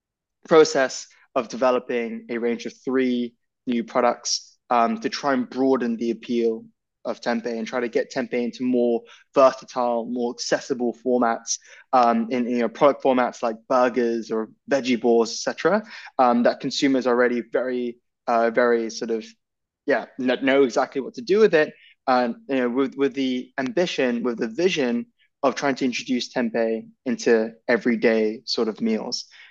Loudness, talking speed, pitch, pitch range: -23 LUFS, 165 wpm, 125 Hz, 115-135 Hz